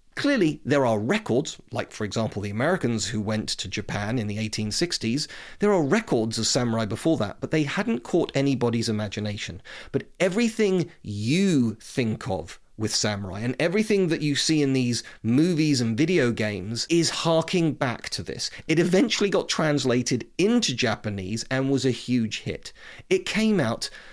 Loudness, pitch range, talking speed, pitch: -25 LUFS, 110-165 Hz, 165 wpm, 125 Hz